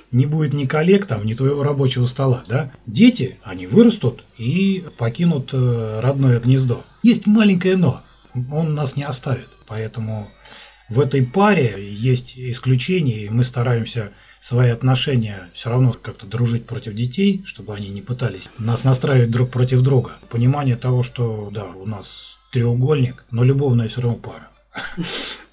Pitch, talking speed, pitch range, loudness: 125 Hz, 145 wpm, 115-140 Hz, -19 LUFS